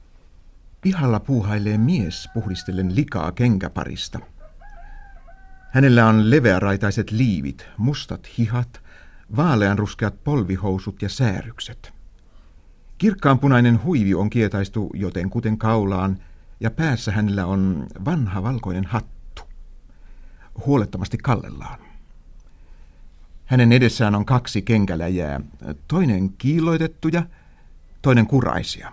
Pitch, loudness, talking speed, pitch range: 105 Hz, -20 LUFS, 85 wpm, 90-120 Hz